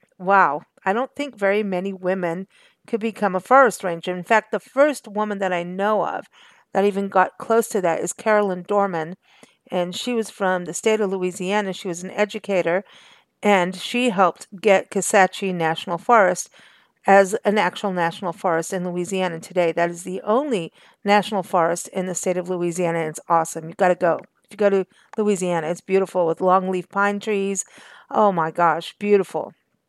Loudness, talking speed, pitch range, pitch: -21 LUFS, 180 wpm, 180-210 Hz, 190 Hz